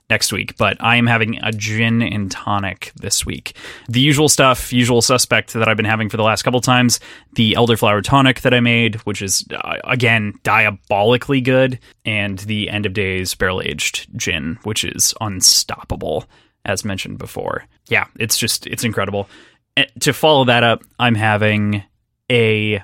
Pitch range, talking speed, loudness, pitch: 105-125 Hz, 175 wpm, -16 LUFS, 115 Hz